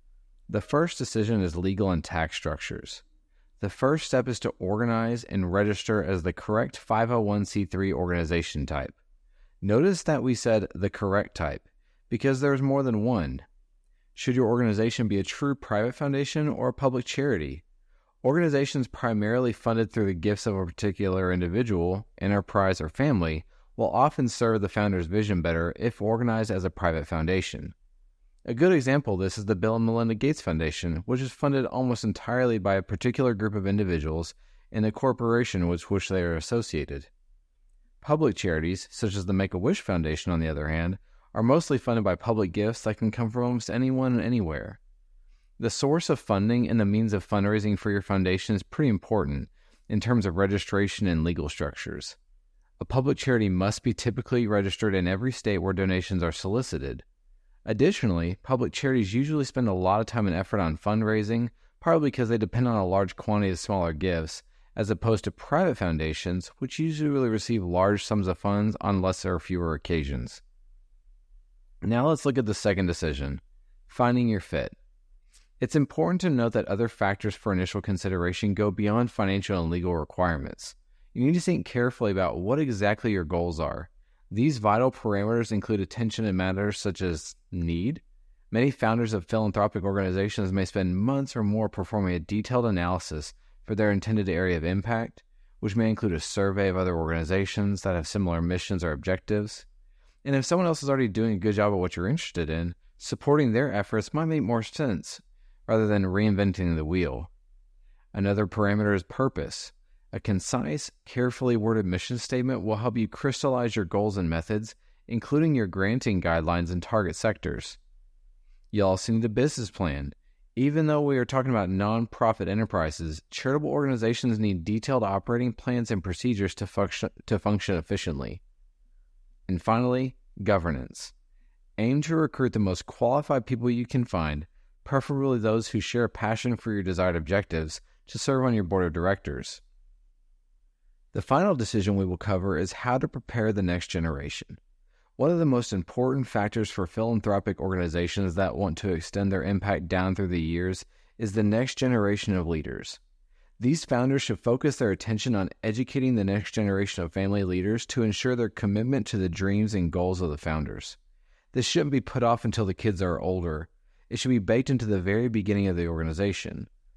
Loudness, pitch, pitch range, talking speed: -27 LUFS, 105 Hz, 90-120 Hz, 175 wpm